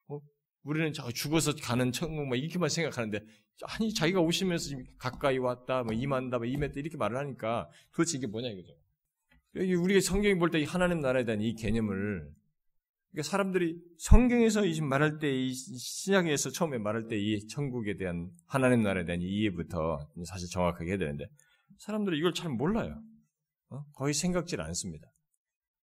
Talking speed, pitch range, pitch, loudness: 350 characters per minute, 110-170 Hz, 140 Hz, -31 LUFS